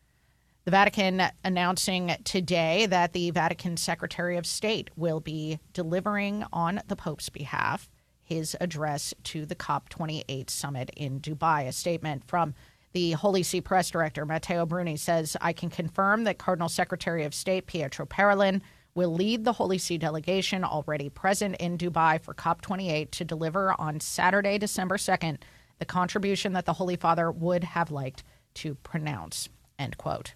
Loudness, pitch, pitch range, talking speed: -28 LUFS, 175 Hz, 160-185 Hz, 150 wpm